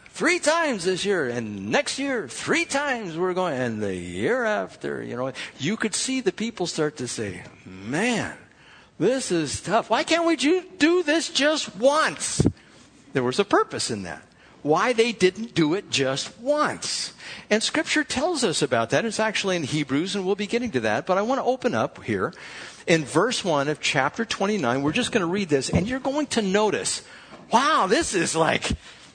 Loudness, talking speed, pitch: -24 LUFS, 190 wpm, 215 Hz